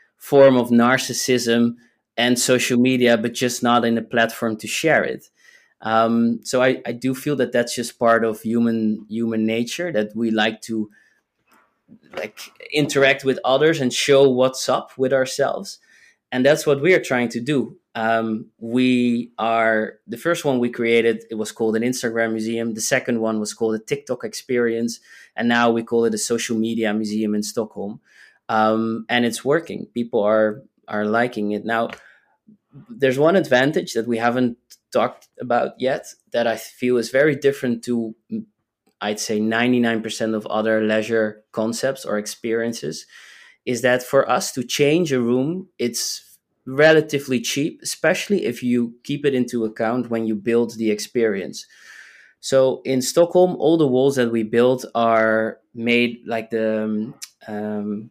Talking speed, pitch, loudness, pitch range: 160 wpm, 120 Hz, -20 LUFS, 110-130 Hz